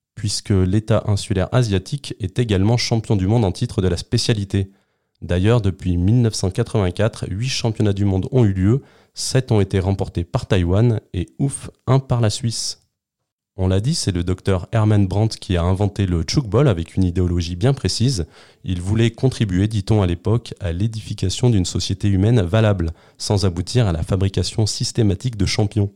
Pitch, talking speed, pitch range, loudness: 105 Hz, 170 wpm, 95-120 Hz, -19 LUFS